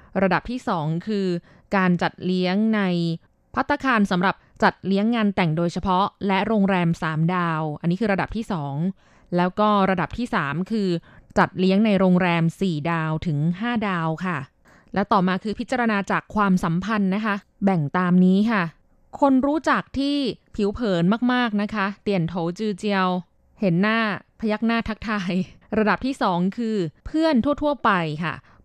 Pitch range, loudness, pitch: 175-220 Hz, -22 LUFS, 195 Hz